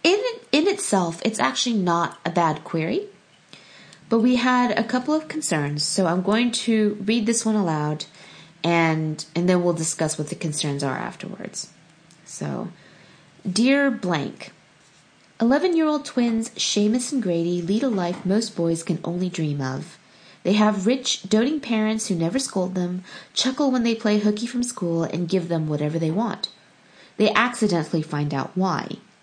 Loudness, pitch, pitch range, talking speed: -23 LUFS, 195 Hz, 165-235 Hz, 160 wpm